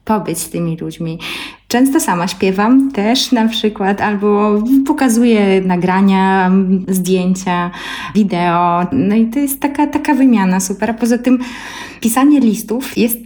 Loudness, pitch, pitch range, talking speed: -14 LUFS, 210 Hz, 185-250 Hz, 130 wpm